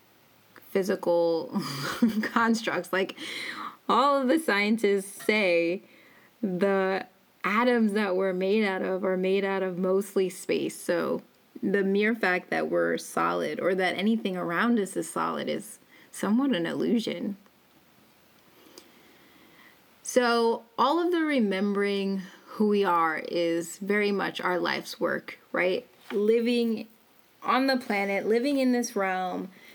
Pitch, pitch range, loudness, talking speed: 200 Hz, 185-230 Hz, -27 LUFS, 125 wpm